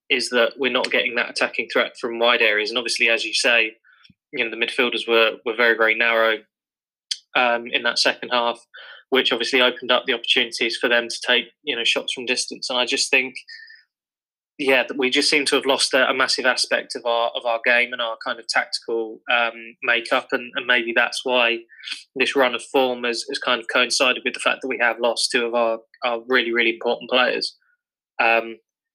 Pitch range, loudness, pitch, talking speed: 115-125 Hz, -20 LUFS, 120 Hz, 210 wpm